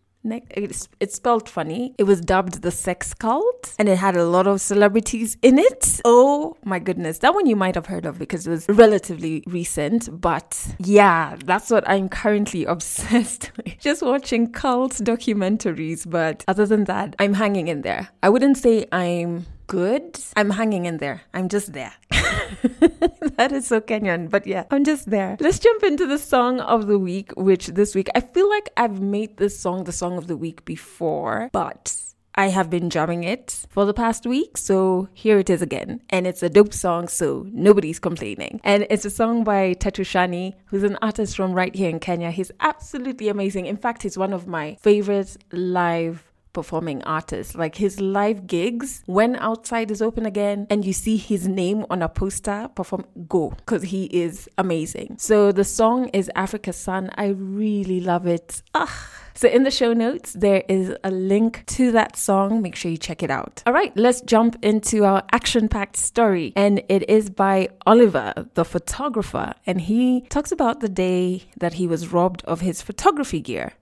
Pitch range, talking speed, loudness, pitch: 180-225 Hz, 190 wpm, -21 LUFS, 200 Hz